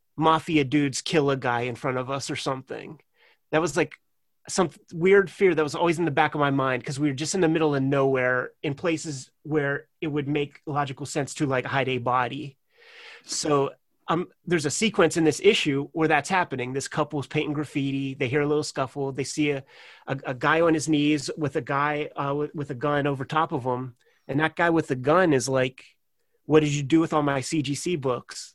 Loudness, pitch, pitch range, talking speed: -25 LUFS, 145 Hz, 135-160 Hz, 225 wpm